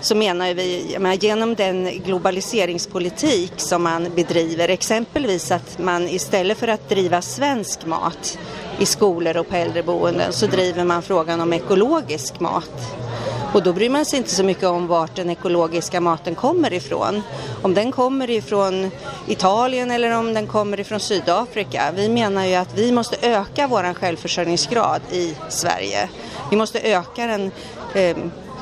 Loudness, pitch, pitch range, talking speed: -20 LUFS, 190 Hz, 175-215 Hz, 150 wpm